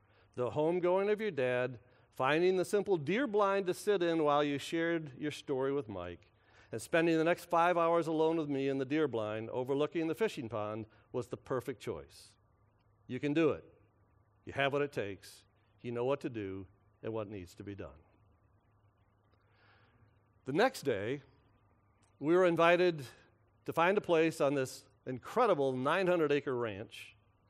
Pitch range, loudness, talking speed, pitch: 105-160 Hz, -33 LUFS, 170 wpm, 125 Hz